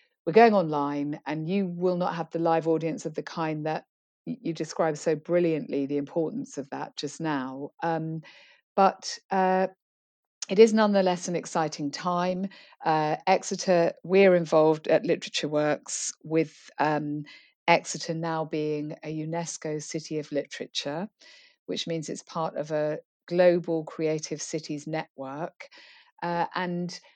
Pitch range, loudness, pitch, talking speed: 155-180 Hz, -27 LUFS, 165 Hz, 140 wpm